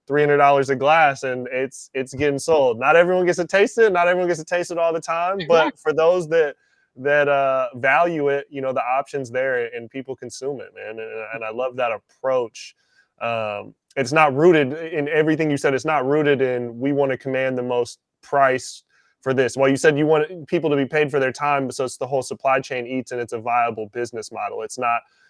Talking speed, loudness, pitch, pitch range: 230 wpm, -20 LUFS, 140 Hz, 130-160 Hz